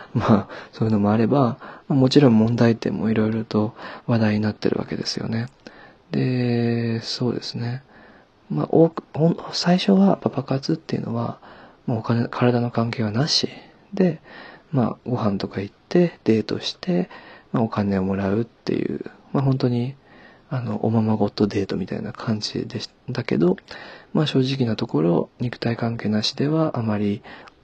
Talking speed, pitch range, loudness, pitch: 305 characters per minute, 110-135 Hz, -22 LUFS, 115 Hz